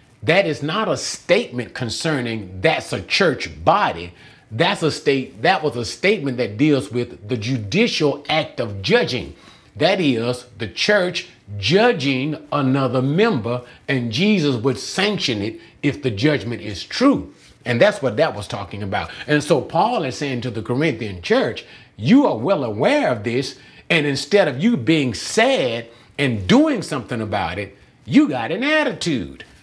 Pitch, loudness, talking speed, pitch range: 135 Hz, -19 LUFS, 160 wpm, 120-160 Hz